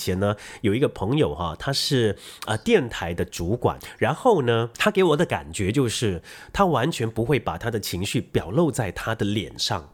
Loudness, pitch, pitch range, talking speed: -24 LUFS, 115 Hz, 100-140 Hz, 280 characters per minute